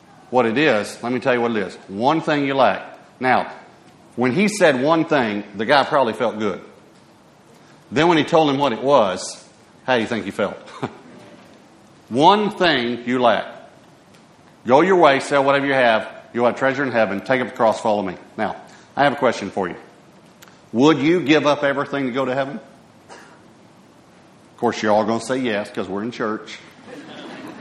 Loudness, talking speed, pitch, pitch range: -19 LUFS, 195 wpm, 130 Hz, 120-145 Hz